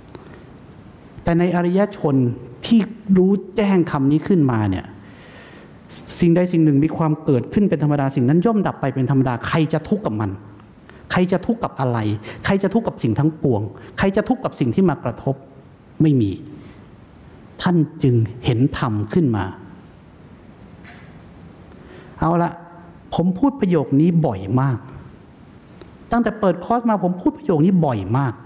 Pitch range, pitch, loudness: 125-185 Hz, 155 Hz, -19 LUFS